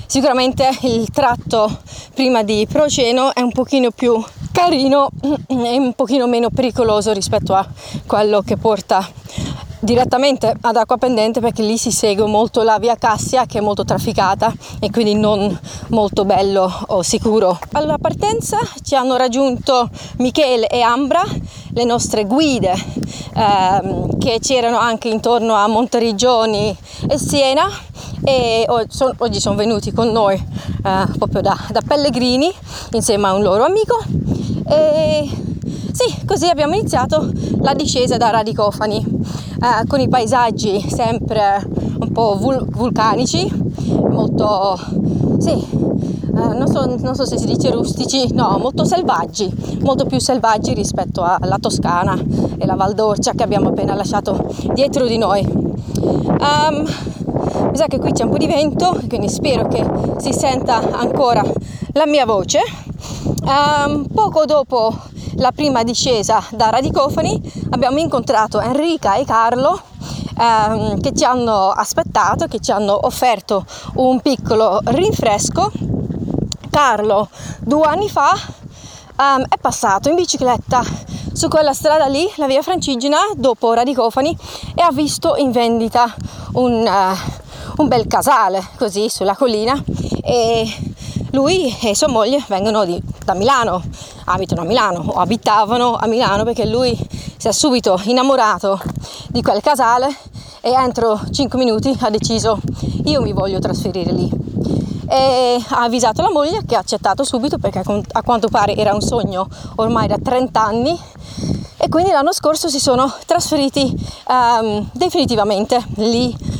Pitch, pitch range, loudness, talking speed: 240 Hz, 215-275 Hz, -16 LUFS, 140 wpm